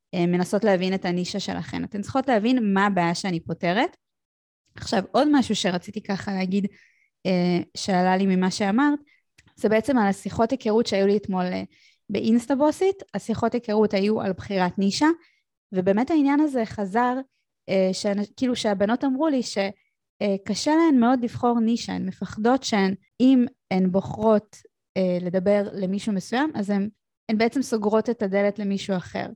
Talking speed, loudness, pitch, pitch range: 140 wpm, -23 LUFS, 205 Hz, 190-240 Hz